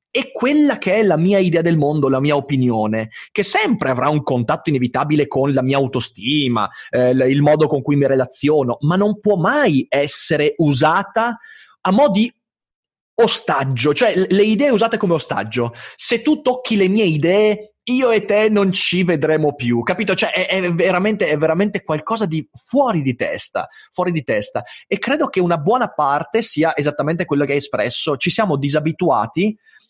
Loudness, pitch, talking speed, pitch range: -17 LUFS, 165 Hz, 175 wpm, 145-210 Hz